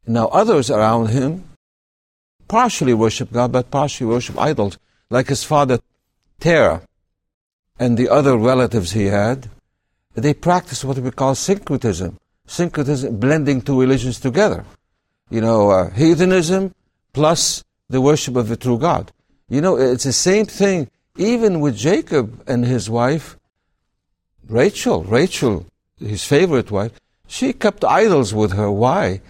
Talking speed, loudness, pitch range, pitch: 135 wpm, -17 LUFS, 110-145 Hz, 125 Hz